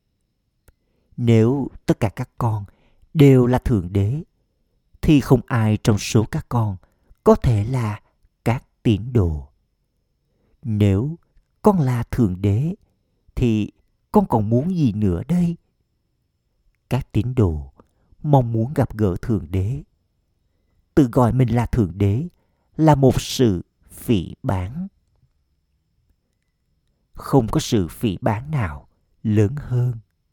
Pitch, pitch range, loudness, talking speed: 110 Hz, 95-130 Hz, -20 LUFS, 125 wpm